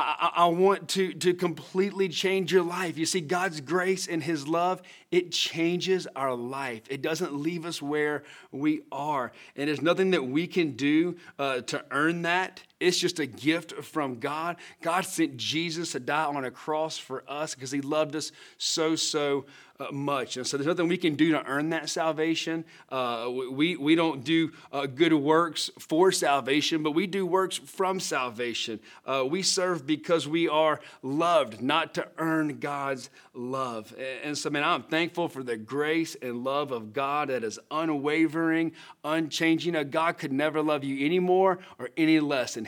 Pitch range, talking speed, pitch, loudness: 140-175 Hz, 180 wpm, 160 Hz, -28 LUFS